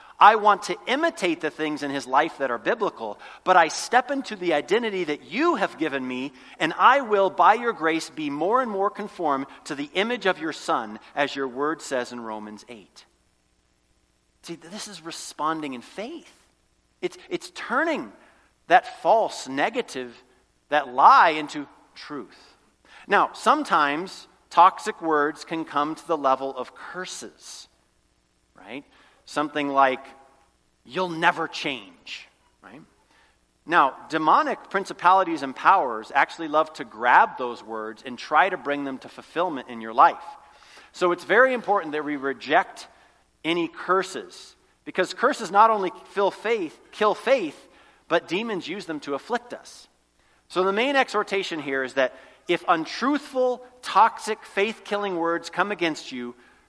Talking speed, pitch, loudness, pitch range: 150 wpm, 165 Hz, -23 LUFS, 135-210 Hz